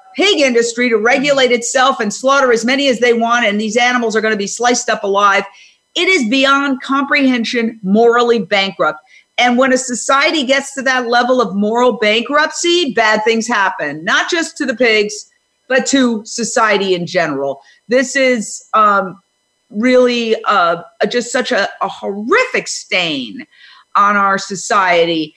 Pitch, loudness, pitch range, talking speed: 240 Hz, -13 LUFS, 210-265 Hz, 155 wpm